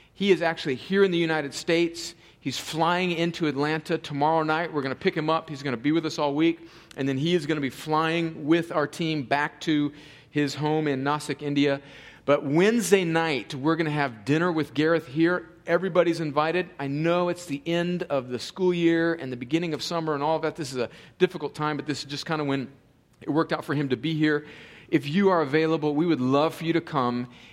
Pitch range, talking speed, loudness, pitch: 145-165 Hz, 235 wpm, -26 LUFS, 155 Hz